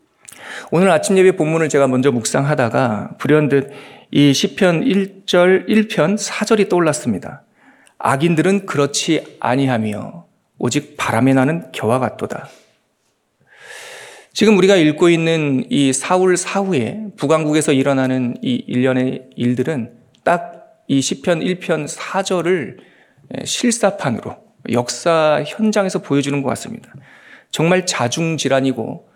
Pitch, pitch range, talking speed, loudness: 160 Hz, 135-195 Hz, 250 characters per minute, -16 LUFS